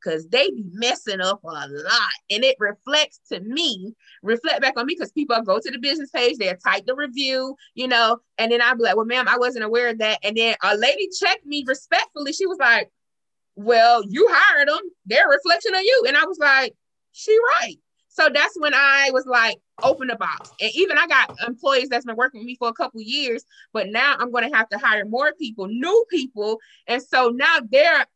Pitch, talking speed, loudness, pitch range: 255 Hz, 220 wpm, -19 LUFS, 230-300 Hz